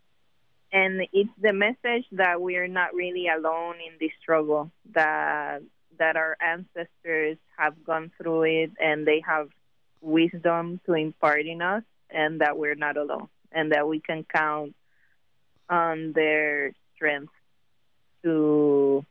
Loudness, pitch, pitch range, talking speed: -25 LUFS, 160 Hz, 155-175 Hz, 135 wpm